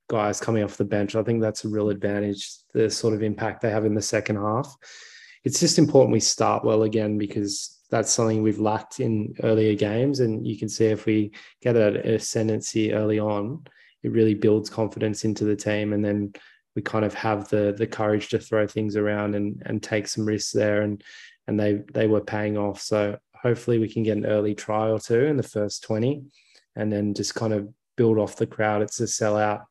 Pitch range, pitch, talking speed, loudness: 105-110 Hz, 110 Hz, 215 wpm, -24 LUFS